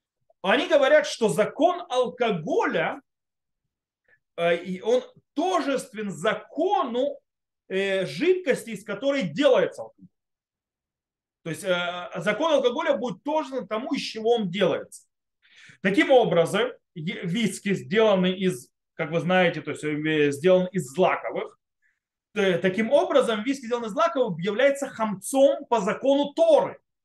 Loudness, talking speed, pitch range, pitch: -24 LUFS, 105 wpm, 185-285 Hz, 225 Hz